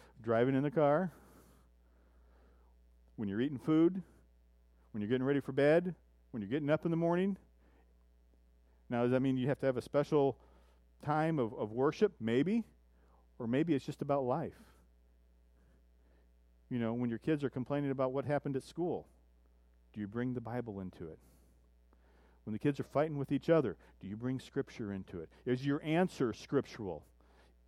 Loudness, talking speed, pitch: -35 LUFS, 170 wpm, 110 Hz